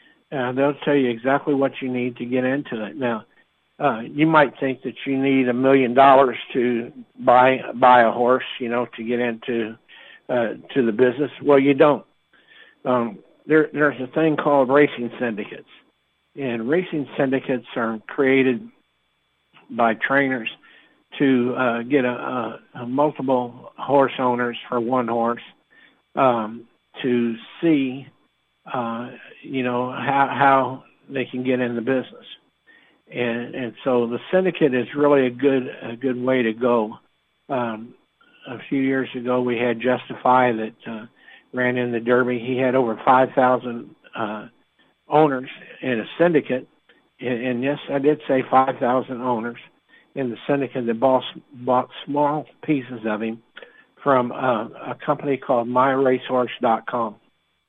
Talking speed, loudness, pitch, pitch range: 150 wpm, -21 LUFS, 125 Hz, 120-135 Hz